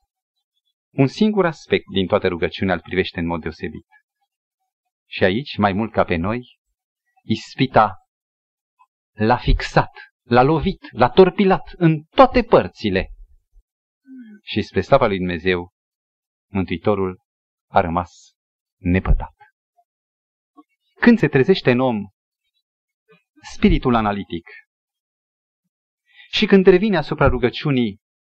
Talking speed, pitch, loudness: 105 wpm, 165 Hz, -19 LUFS